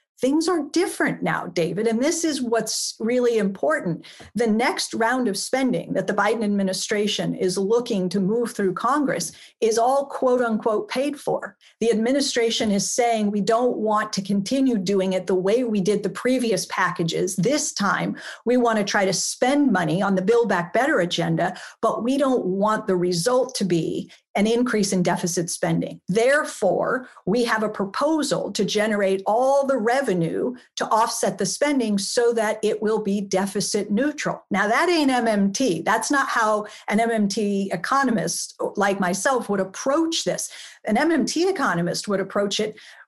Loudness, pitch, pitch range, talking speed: -22 LUFS, 215 Hz, 195-250 Hz, 165 wpm